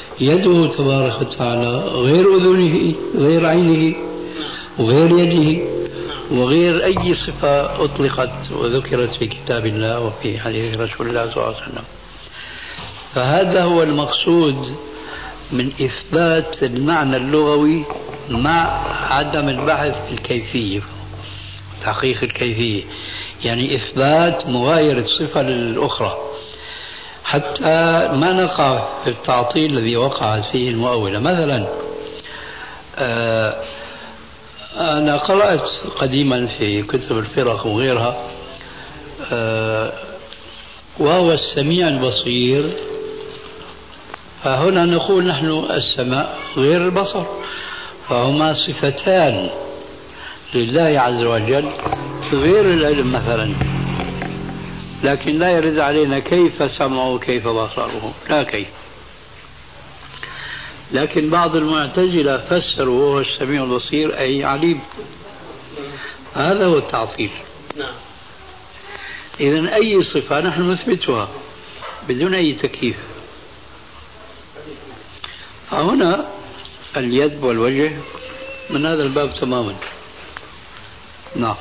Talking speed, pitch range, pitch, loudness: 85 wpm, 125-165 Hz, 145 Hz, -17 LUFS